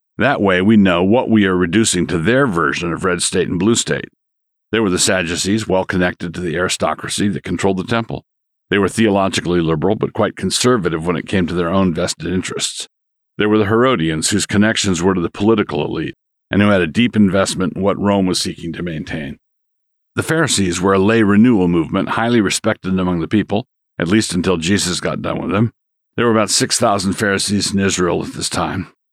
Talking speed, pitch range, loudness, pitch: 205 wpm, 90-110 Hz, -16 LUFS, 95 Hz